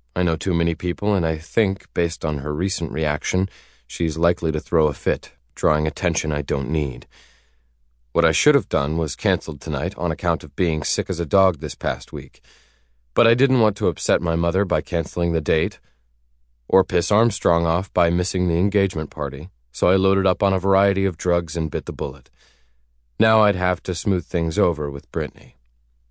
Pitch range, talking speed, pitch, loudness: 75-95 Hz, 200 wpm, 85 Hz, -21 LUFS